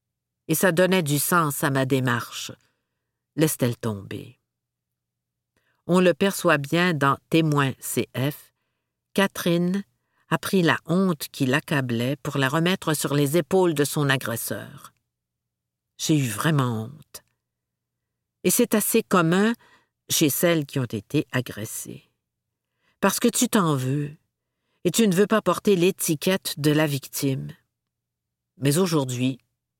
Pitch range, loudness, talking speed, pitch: 125-175 Hz, -23 LUFS, 130 wpm, 150 Hz